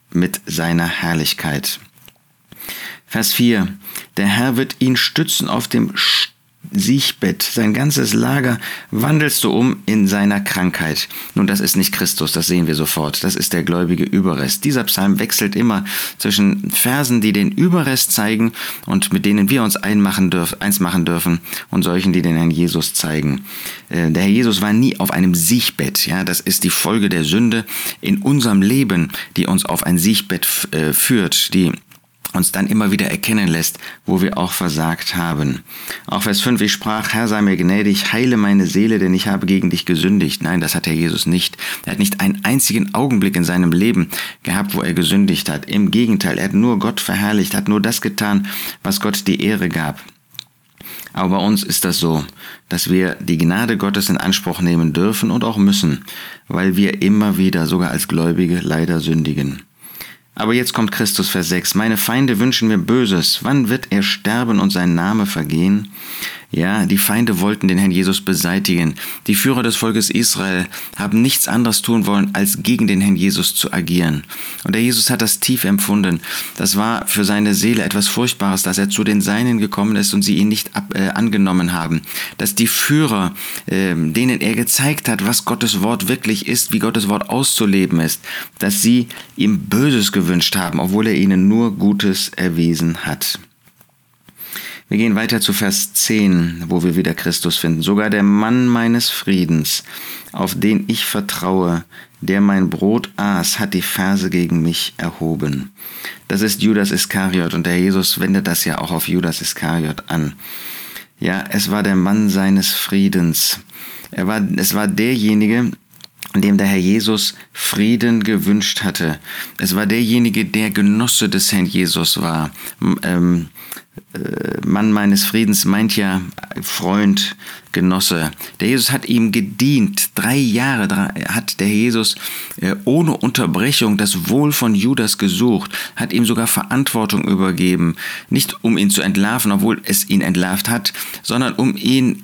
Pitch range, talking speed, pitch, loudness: 90-115 Hz, 170 wpm, 100 Hz, -16 LUFS